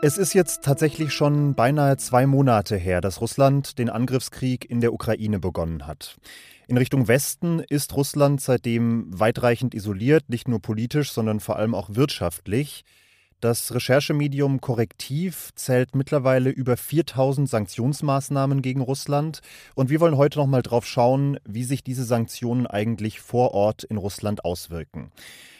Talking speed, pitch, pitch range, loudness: 145 wpm, 125 Hz, 115-140 Hz, -23 LUFS